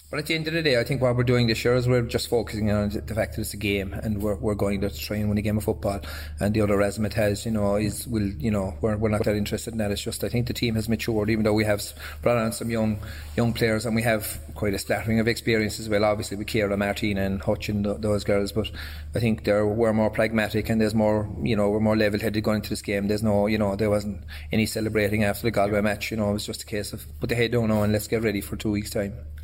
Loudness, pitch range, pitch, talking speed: -25 LUFS, 100-110 Hz, 105 Hz, 300 wpm